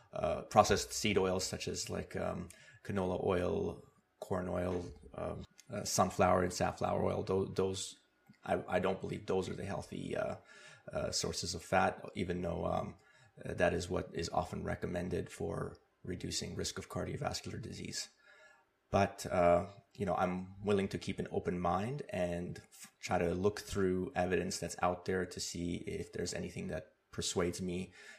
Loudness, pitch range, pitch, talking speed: -37 LUFS, 90-95 Hz, 90 Hz, 165 wpm